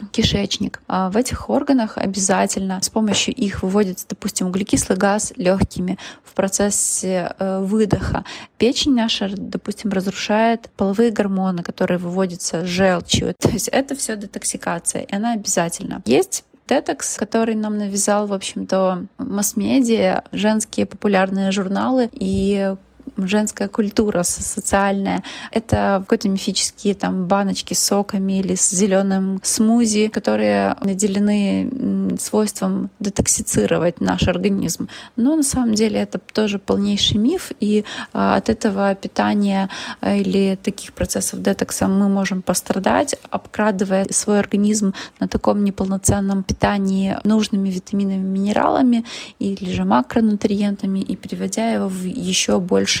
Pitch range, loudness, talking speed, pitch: 195-220 Hz, -19 LUFS, 115 wpm, 205 Hz